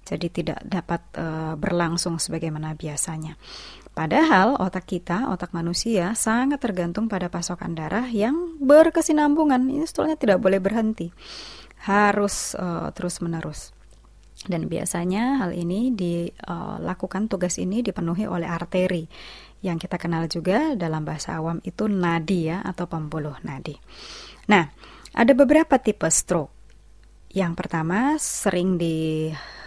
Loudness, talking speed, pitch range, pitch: -23 LUFS, 120 wpm, 170-215 Hz, 180 Hz